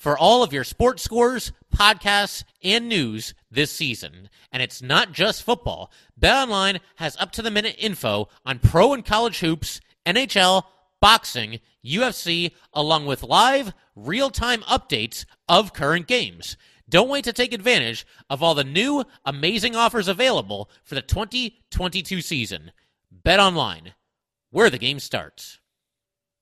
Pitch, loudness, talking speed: 185 Hz, -20 LUFS, 130 wpm